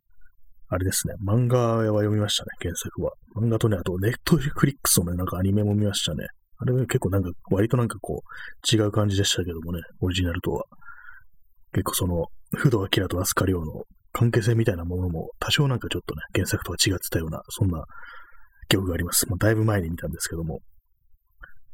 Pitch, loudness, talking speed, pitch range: 100 Hz, -25 LUFS, 410 characters per minute, 90-115 Hz